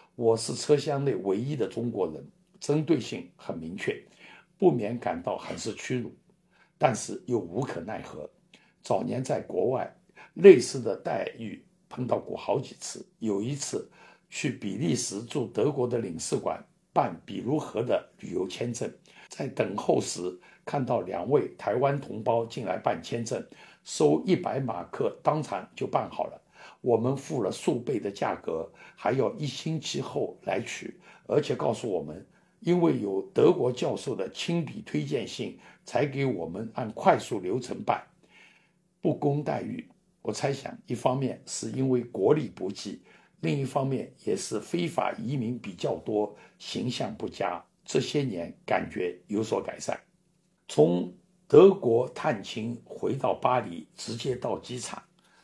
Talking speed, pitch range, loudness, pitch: 220 characters per minute, 115-170 Hz, -29 LUFS, 140 Hz